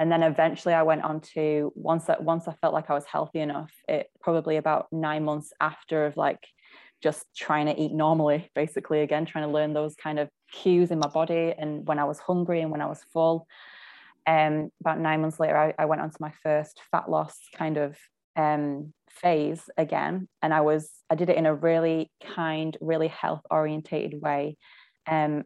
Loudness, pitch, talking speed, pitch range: -27 LUFS, 155 Hz, 205 wpm, 150-165 Hz